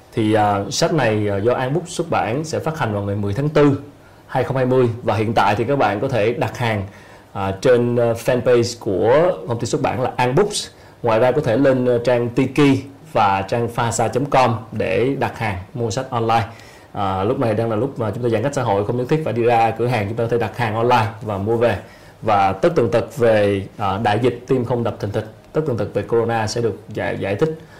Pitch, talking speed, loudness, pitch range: 120 Hz, 240 wpm, -19 LUFS, 110-130 Hz